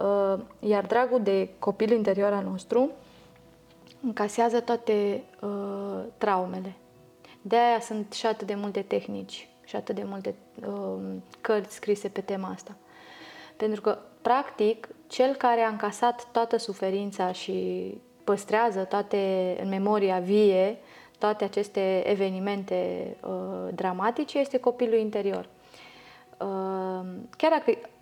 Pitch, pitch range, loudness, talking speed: 205 Hz, 190-230 Hz, -28 LUFS, 115 wpm